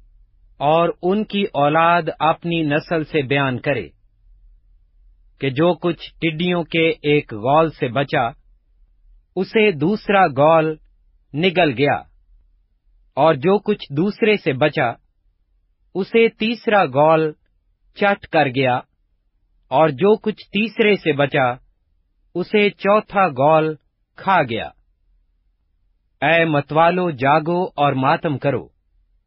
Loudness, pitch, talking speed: -18 LUFS, 150 Hz, 105 wpm